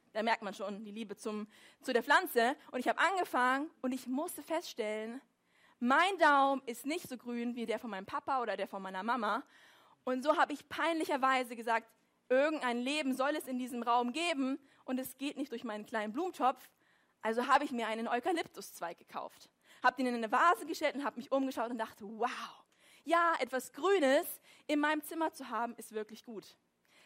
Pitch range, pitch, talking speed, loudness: 230-300 Hz, 255 Hz, 195 wpm, -34 LUFS